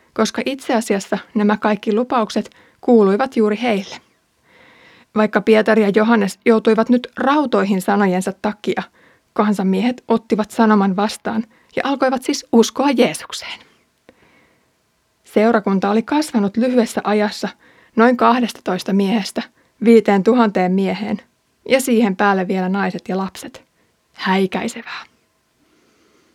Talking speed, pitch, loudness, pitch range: 105 wpm, 220 Hz, -17 LUFS, 205-235 Hz